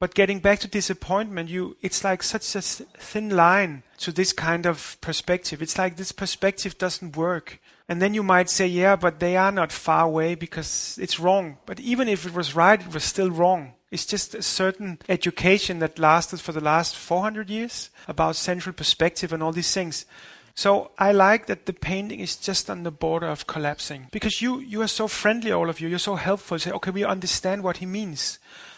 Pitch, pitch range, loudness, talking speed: 185 Hz, 165-195 Hz, -23 LUFS, 210 wpm